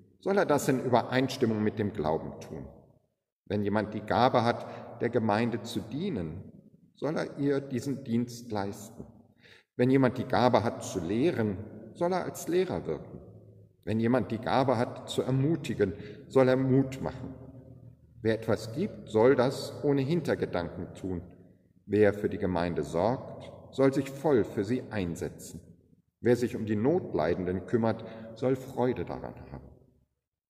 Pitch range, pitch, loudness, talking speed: 100-130 Hz, 115 Hz, -29 LUFS, 150 wpm